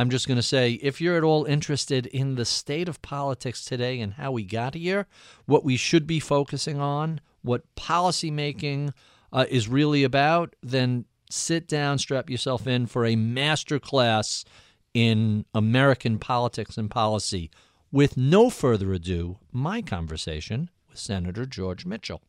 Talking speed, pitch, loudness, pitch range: 155 wpm, 130 Hz, -25 LUFS, 115-145 Hz